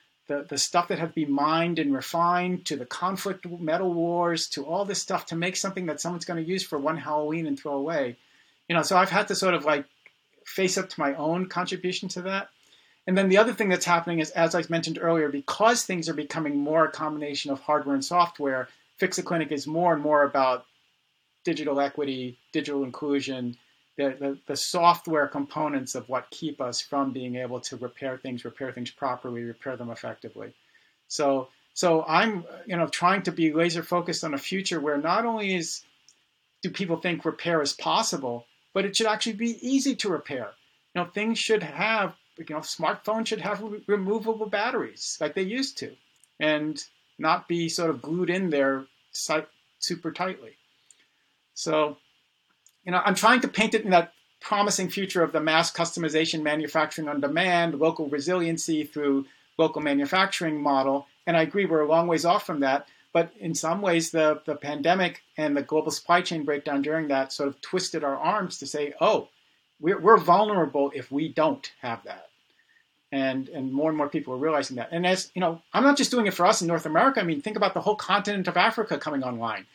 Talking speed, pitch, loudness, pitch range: 195 wpm, 160 Hz, -26 LUFS, 145-180 Hz